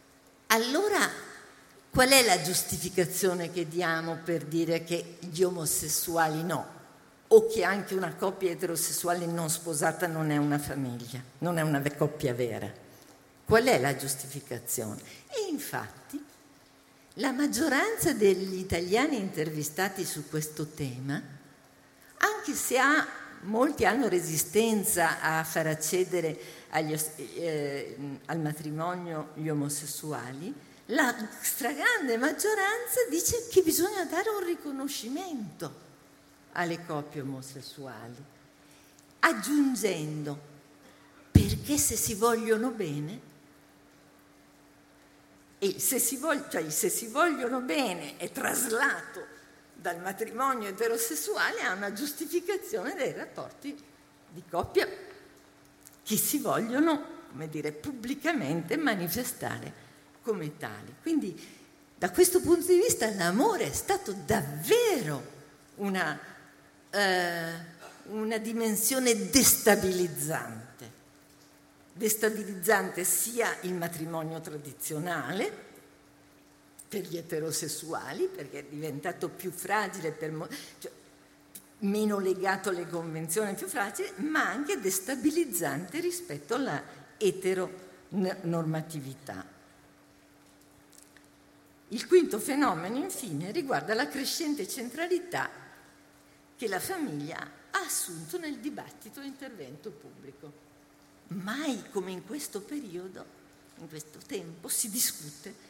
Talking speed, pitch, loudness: 100 wpm, 190 Hz, -29 LUFS